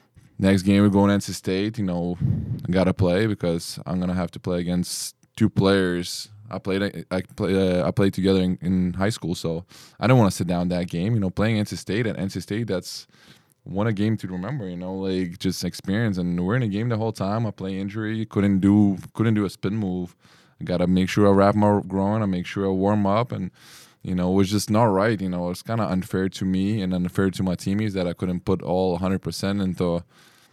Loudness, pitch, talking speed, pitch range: -23 LUFS, 95 Hz, 250 wpm, 90-105 Hz